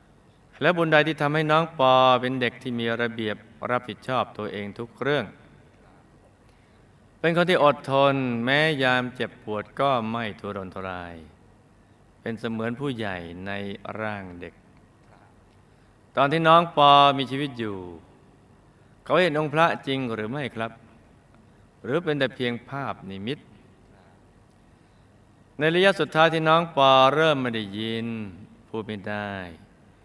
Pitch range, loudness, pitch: 105-135 Hz, -23 LUFS, 115 Hz